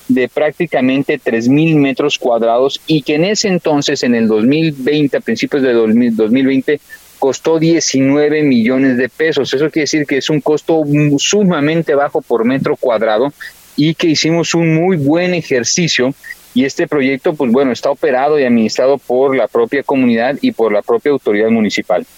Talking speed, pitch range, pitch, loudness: 160 wpm, 130-160 Hz, 145 Hz, -13 LUFS